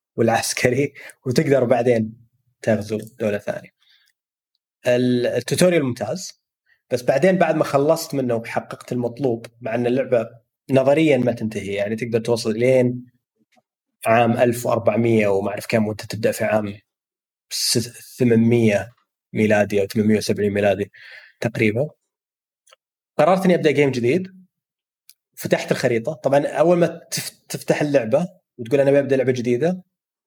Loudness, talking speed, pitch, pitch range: -20 LUFS, 115 wpm, 125 Hz, 115-145 Hz